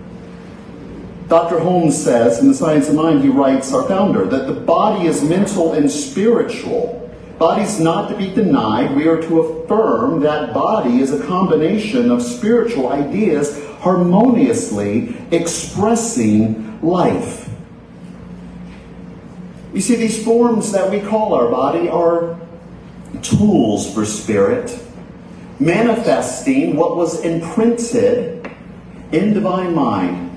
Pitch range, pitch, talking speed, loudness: 155-230 Hz, 175 Hz, 115 wpm, -16 LUFS